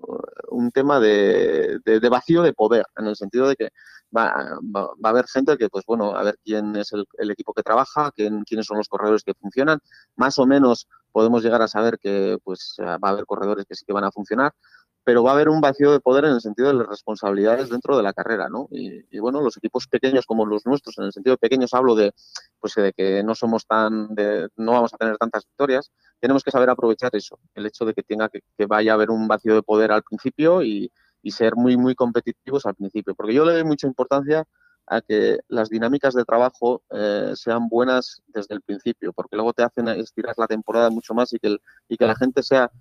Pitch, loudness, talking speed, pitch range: 115 Hz, -21 LUFS, 235 wpm, 105-130 Hz